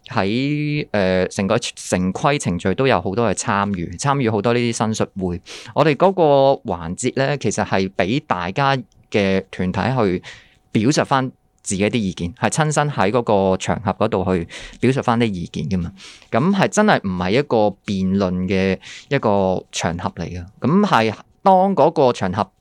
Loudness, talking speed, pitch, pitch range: -19 LUFS, 245 characters per minute, 105 Hz, 95-130 Hz